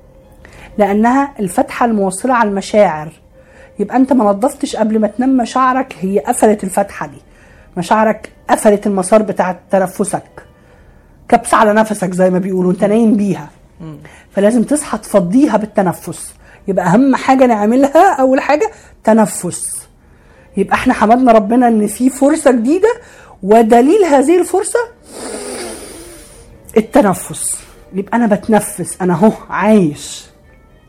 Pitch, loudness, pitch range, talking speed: 215 Hz, -13 LUFS, 195-255 Hz, 115 wpm